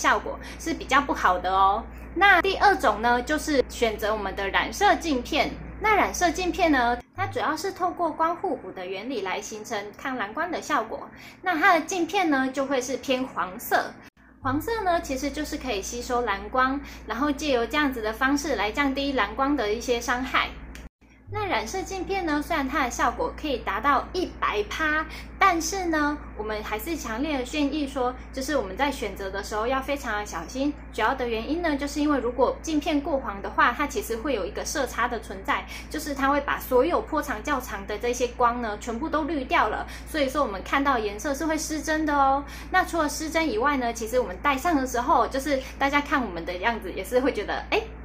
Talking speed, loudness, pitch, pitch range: 305 characters per minute, -25 LUFS, 280 Hz, 240-315 Hz